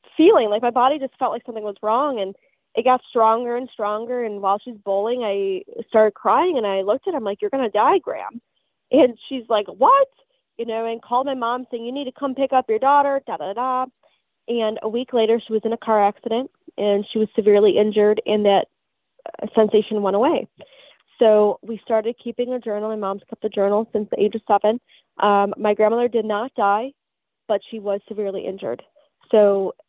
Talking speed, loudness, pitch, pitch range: 205 wpm, -20 LUFS, 225 Hz, 210-245 Hz